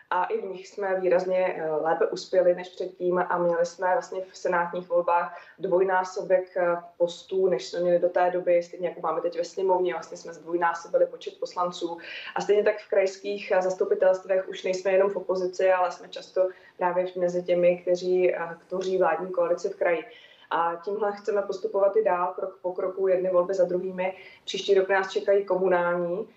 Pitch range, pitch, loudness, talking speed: 175-190 Hz, 185 Hz, -26 LUFS, 175 wpm